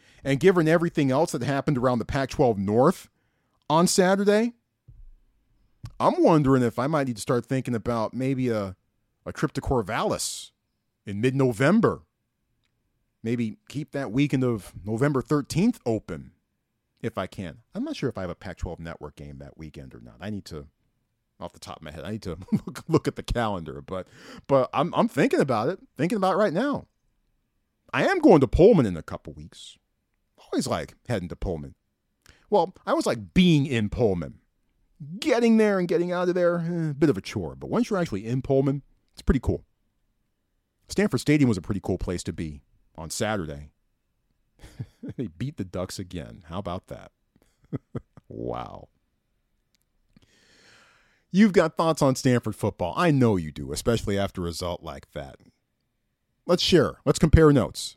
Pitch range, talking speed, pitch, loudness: 95-150 Hz, 175 wpm, 120 Hz, -24 LUFS